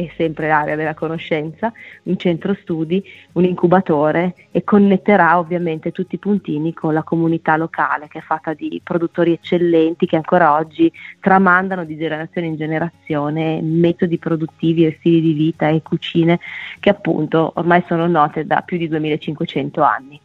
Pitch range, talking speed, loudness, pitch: 160-175 Hz, 155 wpm, -17 LUFS, 165 Hz